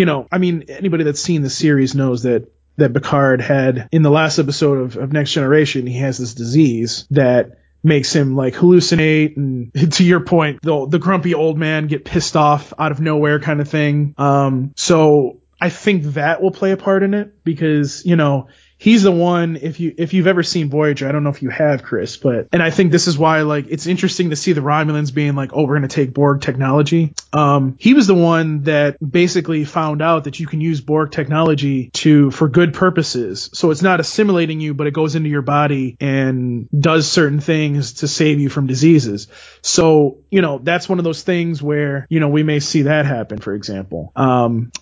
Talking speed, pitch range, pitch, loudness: 215 wpm, 140-165 Hz, 150 Hz, -15 LUFS